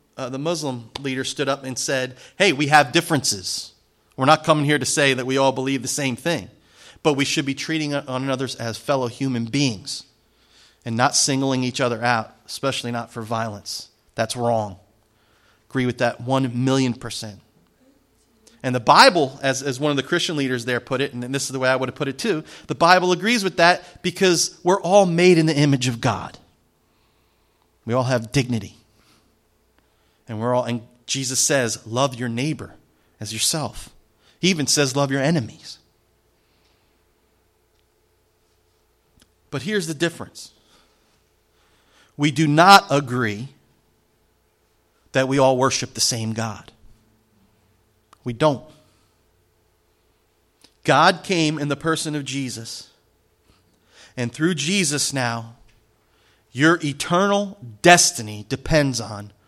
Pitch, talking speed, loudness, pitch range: 130 Hz, 145 wpm, -20 LUFS, 110-145 Hz